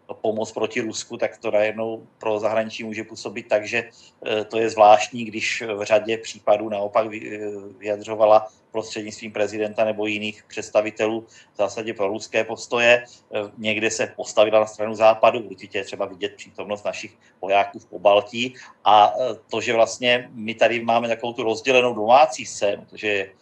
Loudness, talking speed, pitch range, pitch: -22 LUFS, 150 wpm, 105-115 Hz, 110 Hz